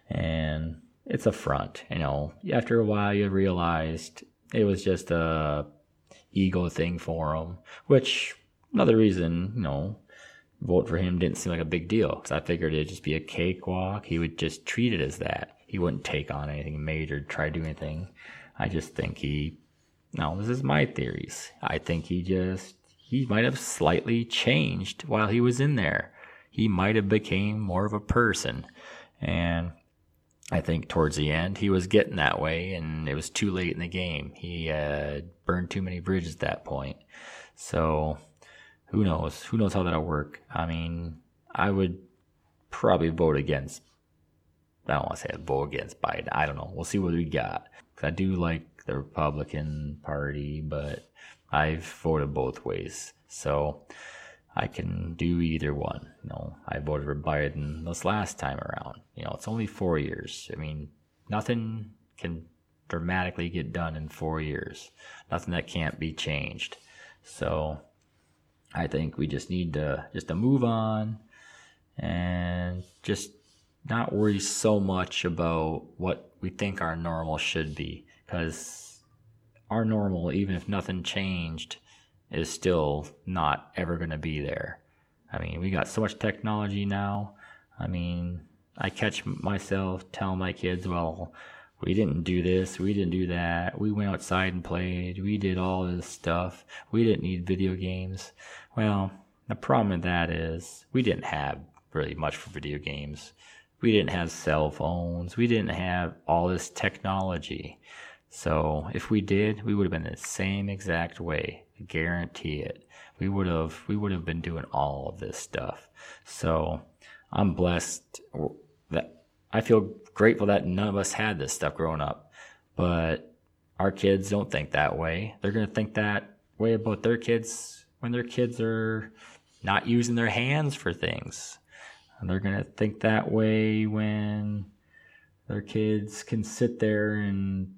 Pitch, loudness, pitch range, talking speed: 90 Hz, -29 LUFS, 80-100 Hz, 170 wpm